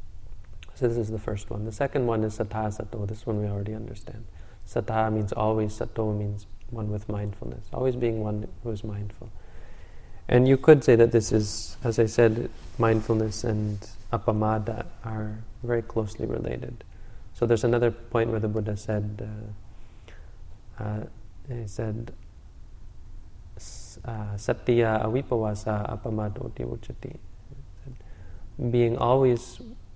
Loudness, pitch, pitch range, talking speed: -27 LUFS, 110 Hz, 100-115 Hz, 130 wpm